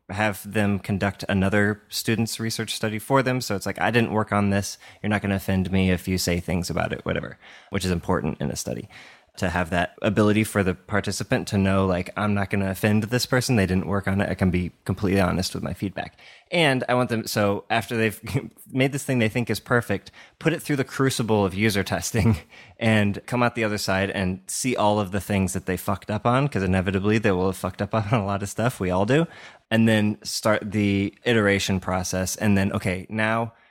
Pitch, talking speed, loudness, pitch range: 100 Hz, 230 wpm, -24 LUFS, 95-115 Hz